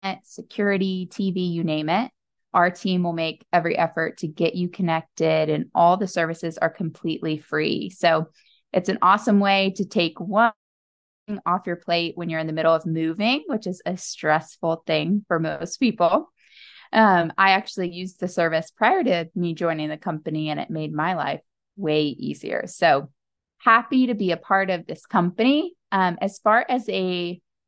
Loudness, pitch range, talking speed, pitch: -23 LUFS, 165-195 Hz, 180 wpm, 175 Hz